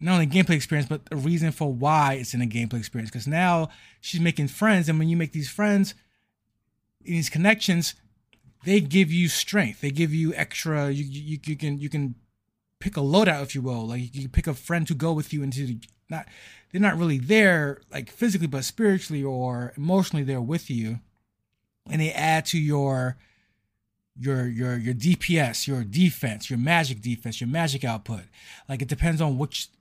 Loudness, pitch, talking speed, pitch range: -25 LUFS, 140 Hz, 195 wpm, 120-165 Hz